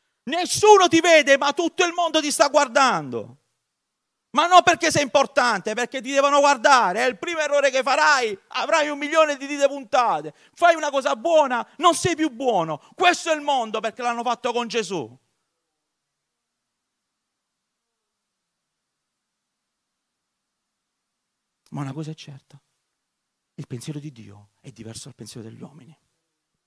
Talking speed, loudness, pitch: 140 wpm, -19 LUFS, 275 Hz